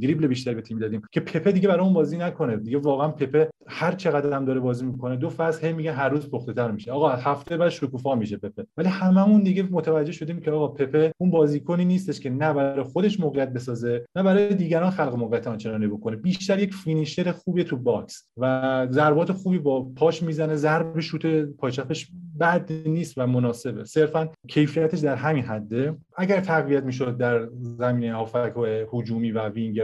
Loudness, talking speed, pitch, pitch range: -24 LUFS, 185 wpm, 150 Hz, 125-165 Hz